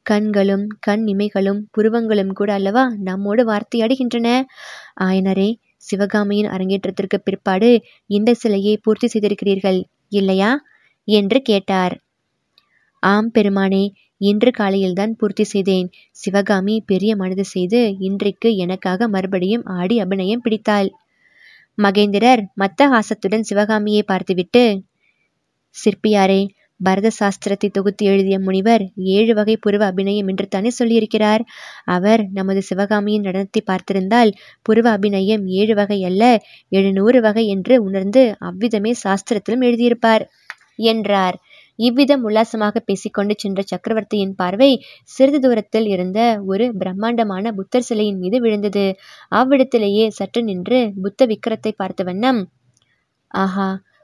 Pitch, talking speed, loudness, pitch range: 205 Hz, 105 wpm, -17 LUFS, 195-225 Hz